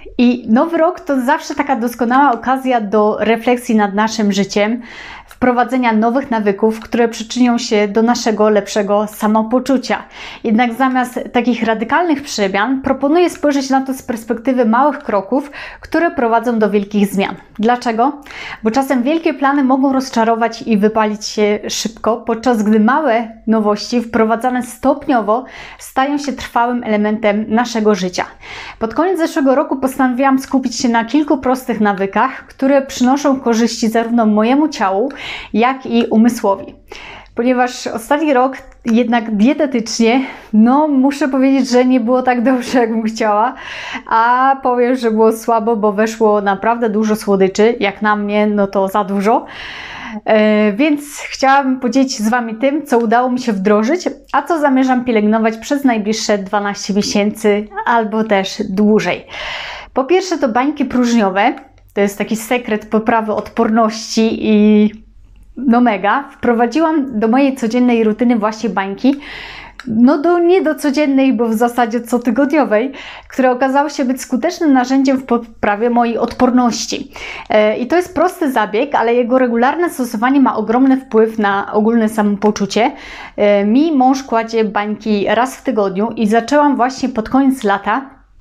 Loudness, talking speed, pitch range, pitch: -14 LUFS, 145 wpm, 220-265 Hz, 240 Hz